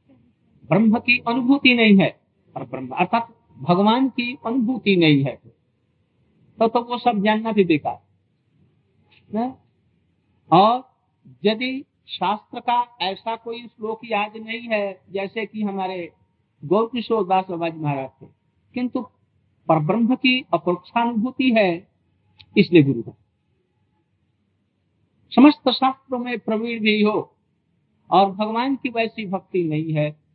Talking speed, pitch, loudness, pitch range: 120 wpm, 205 Hz, -20 LUFS, 150-235 Hz